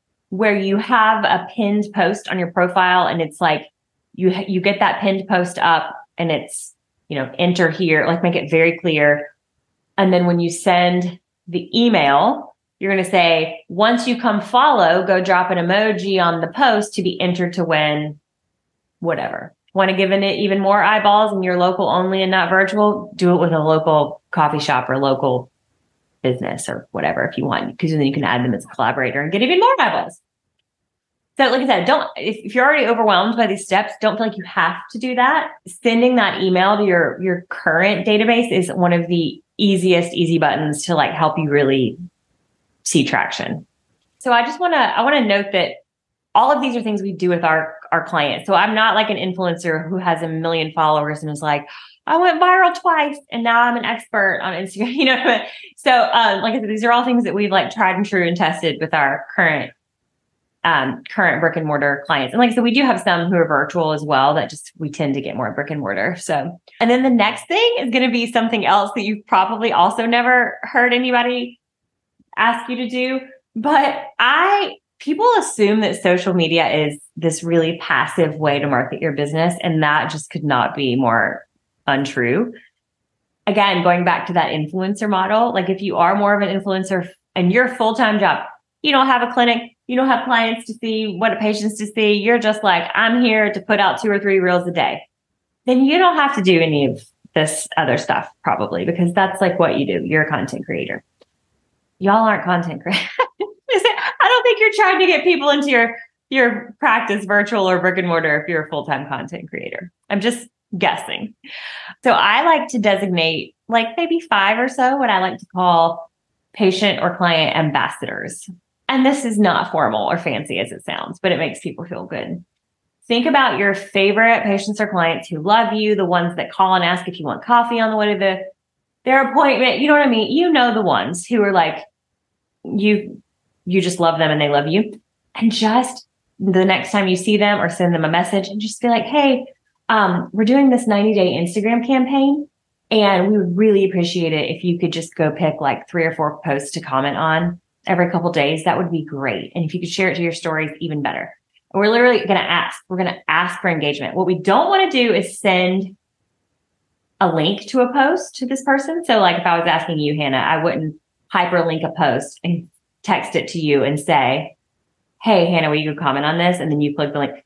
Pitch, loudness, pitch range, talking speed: 190 Hz, -17 LUFS, 165-230 Hz, 215 wpm